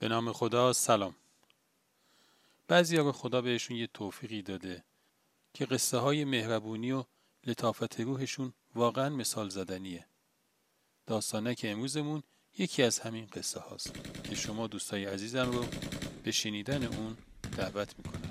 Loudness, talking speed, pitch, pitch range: -33 LUFS, 130 wpm, 115 Hz, 110-130 Hz